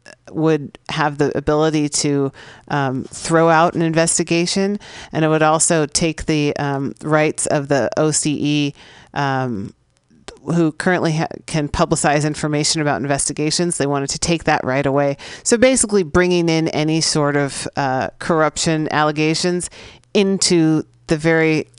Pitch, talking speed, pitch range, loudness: 155 Hz, 140 wpm, 145-165 Hz, -17 LUFS